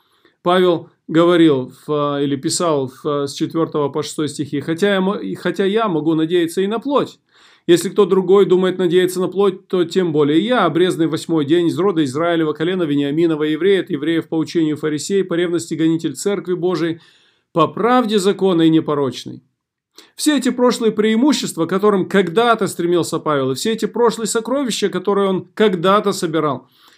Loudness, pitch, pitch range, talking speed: -17 LUFS, 175 Hz, 160-200 Hz, 150 wpm